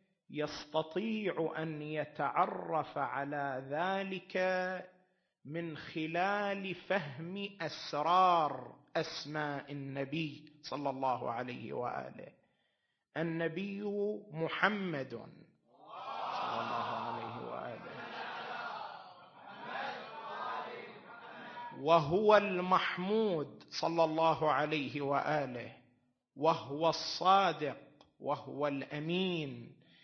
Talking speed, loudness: 60 wpm, -35 LUFS